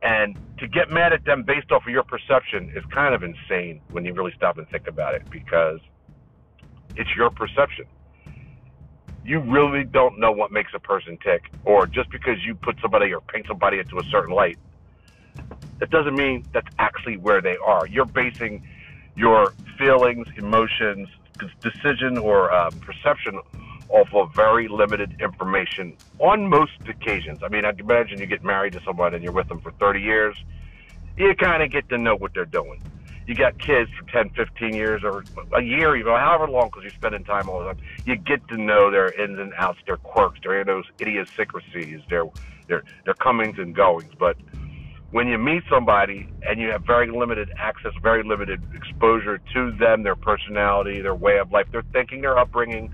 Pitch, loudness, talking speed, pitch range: 105 Hz, -21 LUFS, 185 wpm, 90-120 Hz